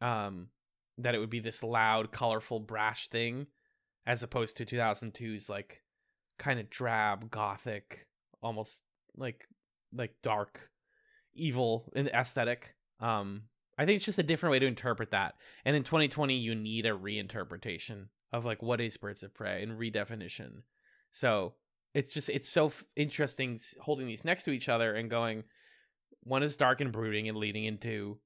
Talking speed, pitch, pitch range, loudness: 160 wpm, 115 Hz, 110-135 Hz, -34 LUFS